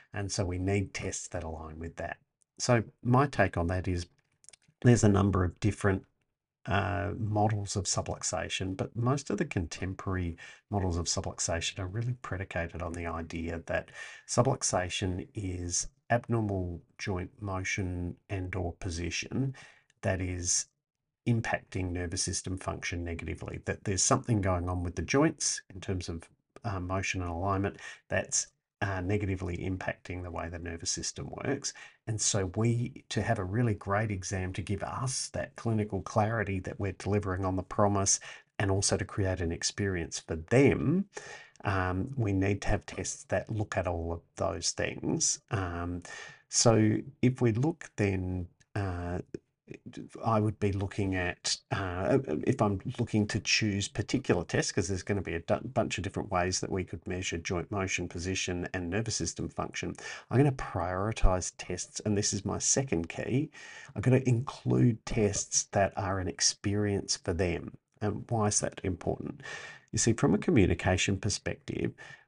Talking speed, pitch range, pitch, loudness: 160 wpm, 90-110 Hz, 100 Hz, -31 LUFS